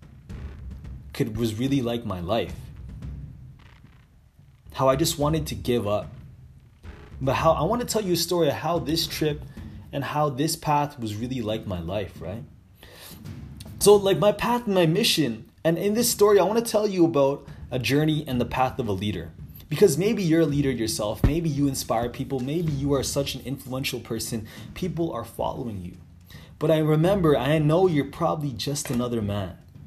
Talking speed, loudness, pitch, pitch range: 185 wpm, -24 LUFS, 140 Hz, 115-160 Hz